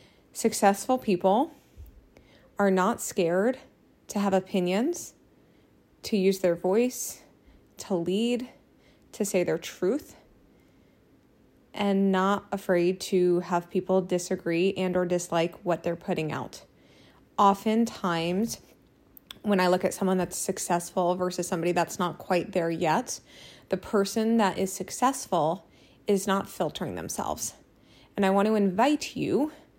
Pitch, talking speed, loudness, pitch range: 190 Hz, 125 wpm, -27 LUFS, 180-205 Hz